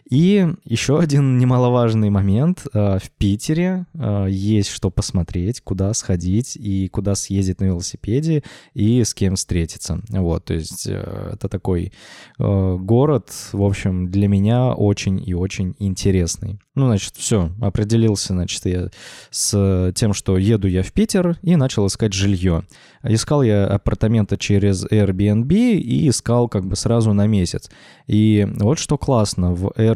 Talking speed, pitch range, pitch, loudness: 140 wpm, 95-120 Hz, 105 Hz, -19 LUFS